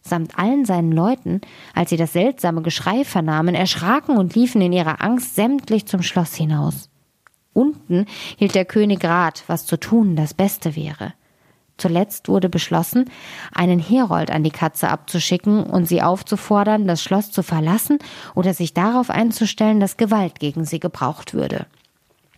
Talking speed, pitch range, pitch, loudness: 155 wpm, 170-215 Hz, 185 Hz, -19 LUFS